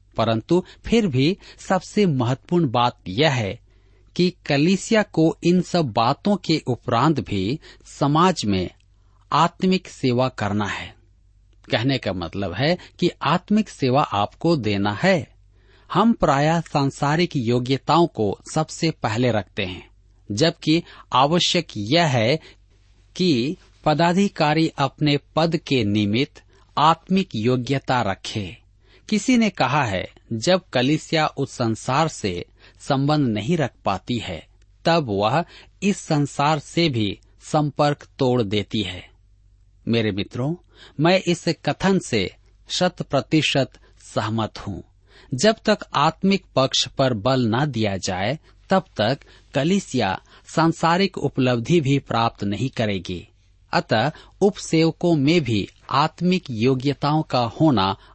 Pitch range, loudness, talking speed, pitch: 105-165 Hz, -21 LUFS, 120 wpm, 135 Hz